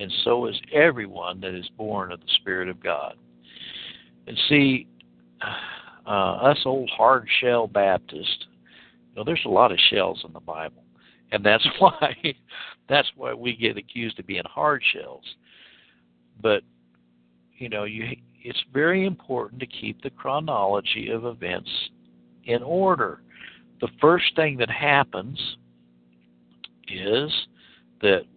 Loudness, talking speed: -23 LUFS, 135 wpm